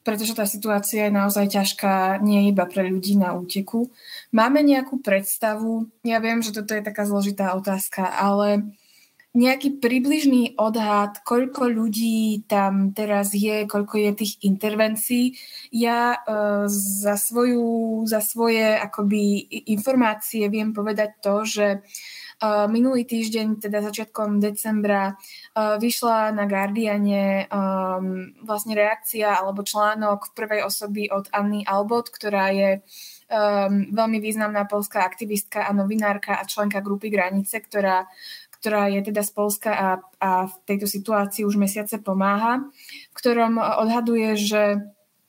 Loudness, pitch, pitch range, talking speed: -22 LUFS, 210 Hz, 200-225 Hz, 125 wpm